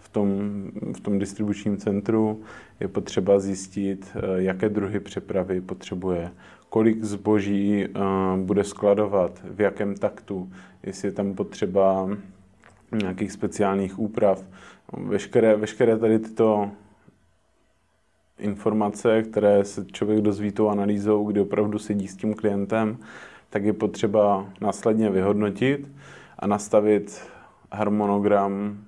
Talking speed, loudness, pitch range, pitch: 110 wpm, -24 LUFS, 100-105 Hz, 105 Hz